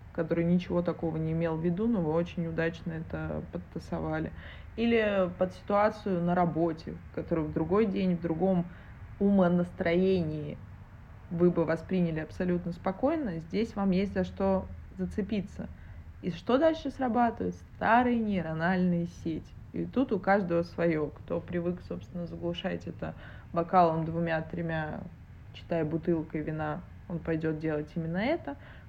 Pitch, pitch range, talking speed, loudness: 170 Hz, 160-190 Hz, 130 wpm, -30 LUFS